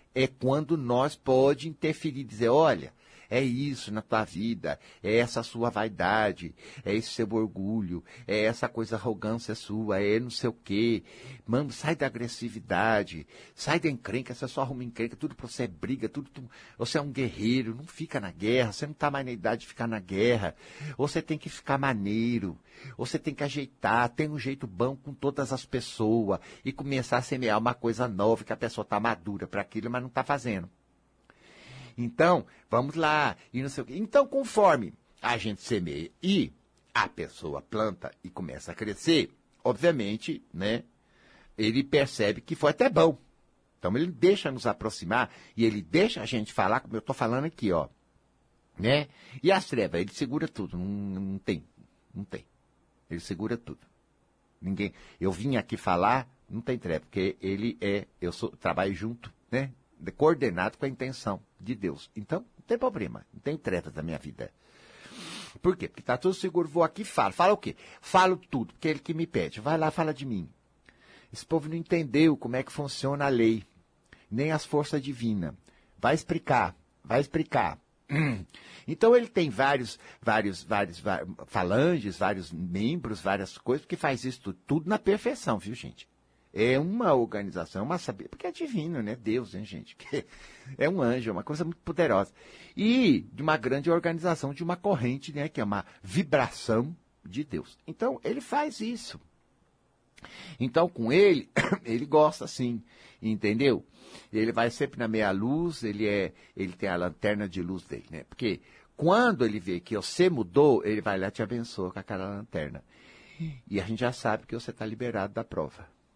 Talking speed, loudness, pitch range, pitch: 180 wpm, -29 LUFS, 105-150 Hz, 120 Hz